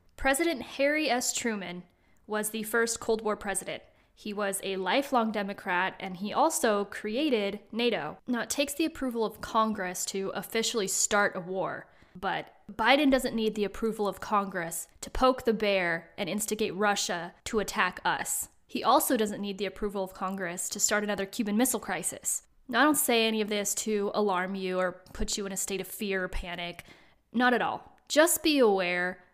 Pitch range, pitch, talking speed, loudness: 195-235 Hz, 210 Hz, 185 wpm, -29 LUFS